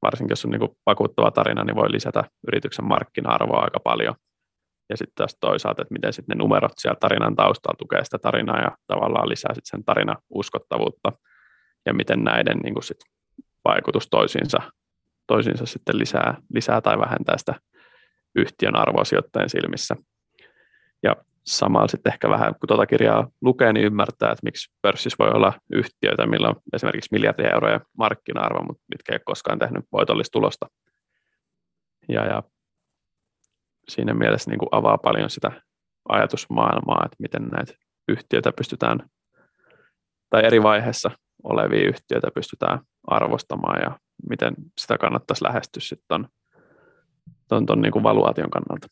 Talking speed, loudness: 140 wpm, -22 LUFS